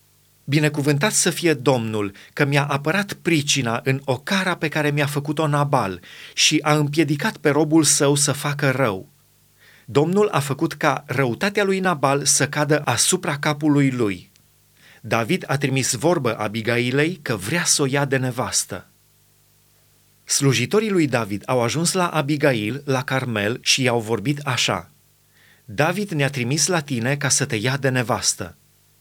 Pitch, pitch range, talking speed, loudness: 140 Hz, 130-155 Hz, 150 wpm, -20 LUFS